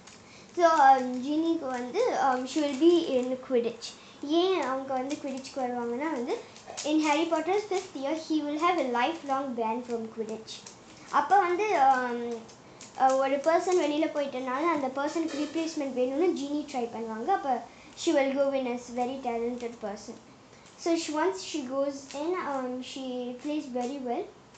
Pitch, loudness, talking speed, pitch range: 275 Hz, -29 LUFS, 145 wpm, 250-320 Hz